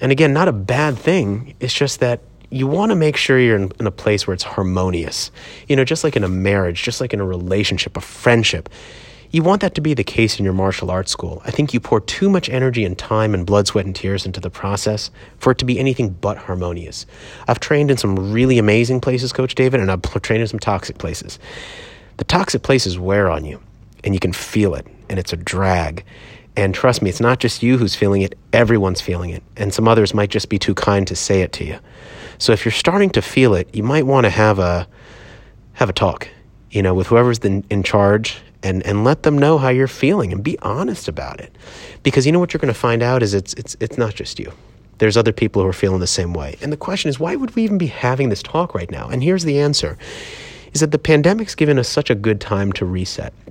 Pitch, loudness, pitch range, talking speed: 110 Hz, -17 LUFS, 95-130 Hz, 245 wpm